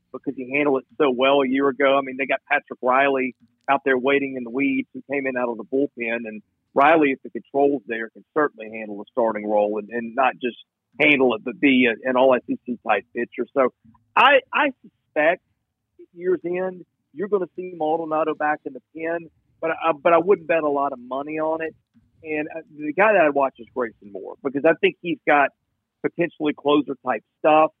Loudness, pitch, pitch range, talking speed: -22 LUFS, 140 Hz, 120-155 Hz, 215 wpm